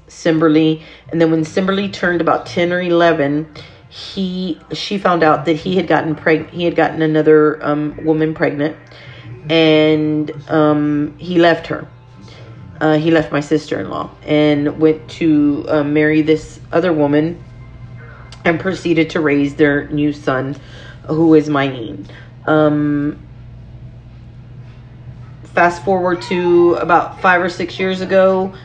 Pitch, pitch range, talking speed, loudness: 155 Hz, 140-165 Hz, 140 wpm, -15 LUFS